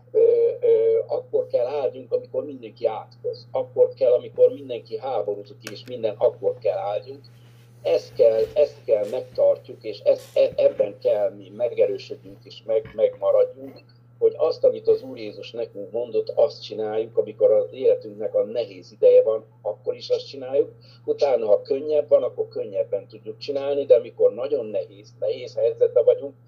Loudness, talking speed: -23 LUFS, 155 wpm